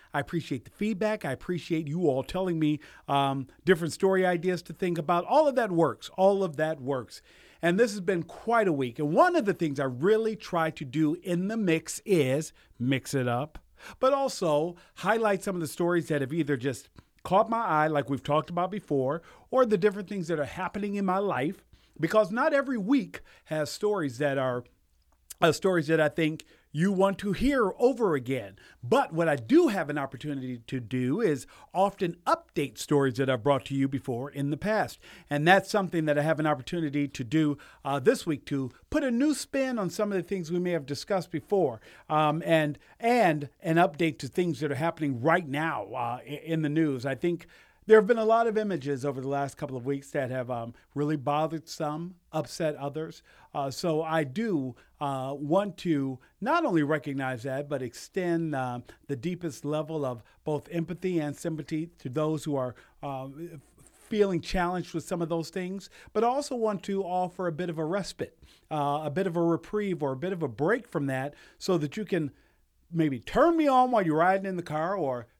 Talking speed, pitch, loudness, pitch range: 205 wpm, 160 Hz, -28 LUFS, 145-190 Hz